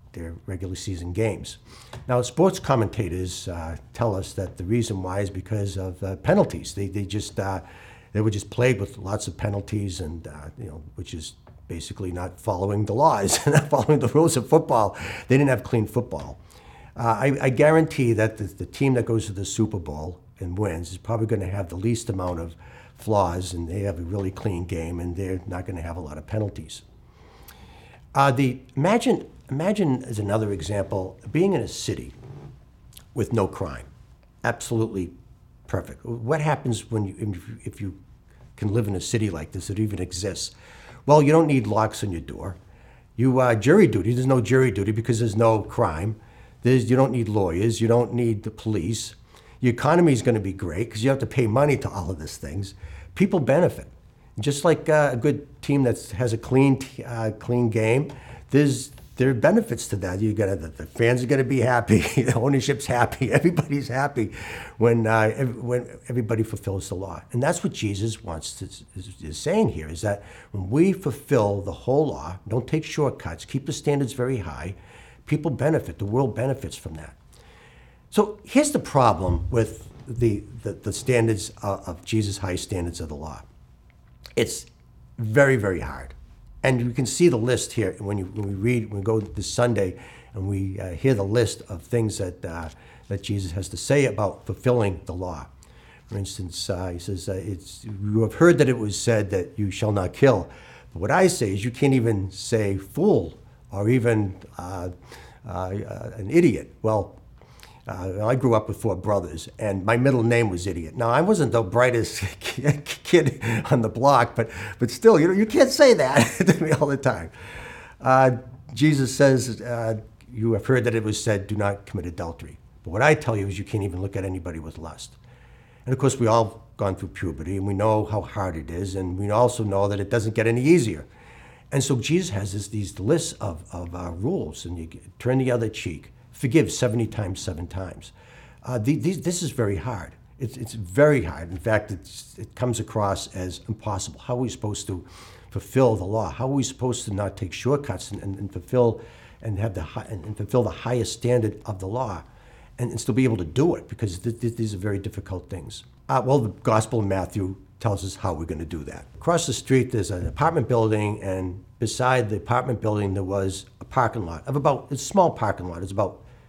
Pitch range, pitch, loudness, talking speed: 95-125 Hz, 110 Hz, -24 LUFS, 205 wpm